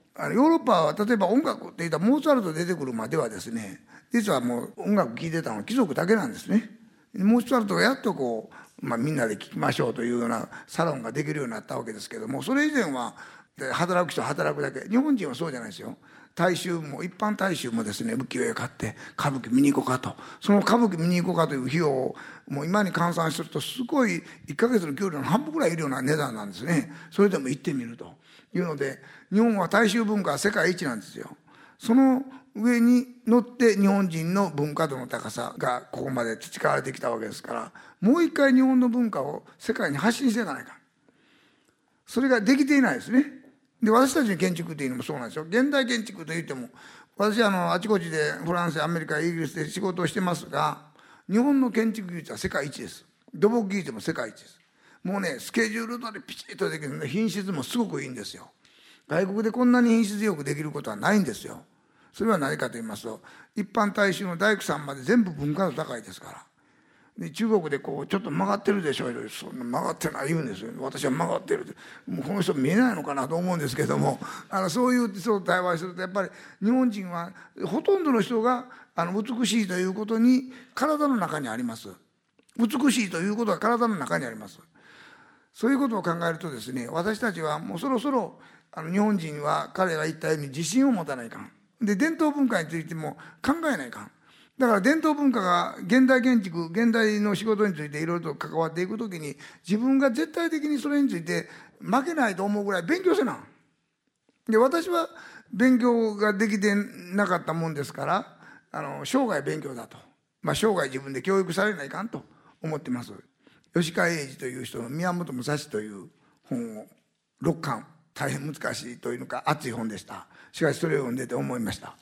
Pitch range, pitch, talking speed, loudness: 160-240 Hz, 200 Hz, 405 characters per minute, -26 LUFS